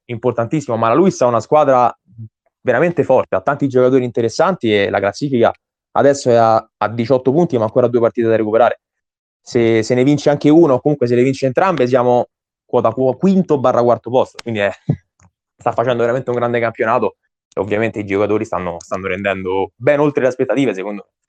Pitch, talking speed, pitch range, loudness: 120 Hz, 180 wpm, 110-135 Hz, -15 LUFS